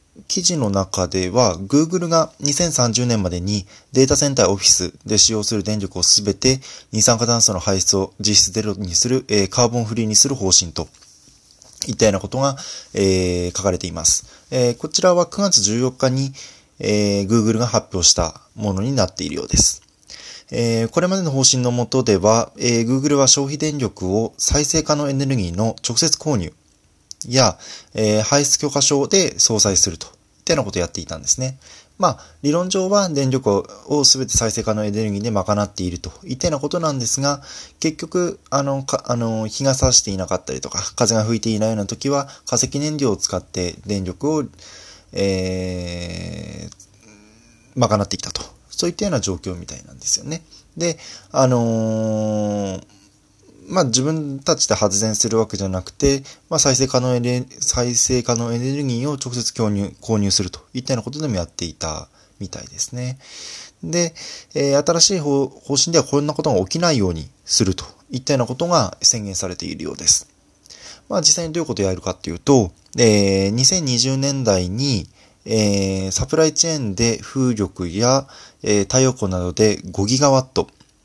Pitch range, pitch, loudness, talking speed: 100-140 Hz, 115 Hz, -18 LUFS, 335 characters per minute